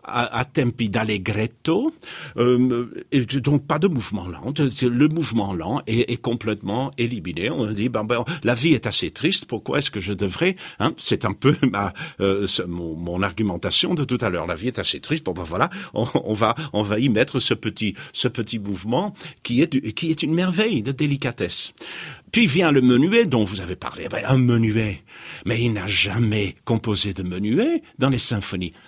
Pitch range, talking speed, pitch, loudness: 105-140 Hz, 200 wpm, 120 Hz, -22 LUFS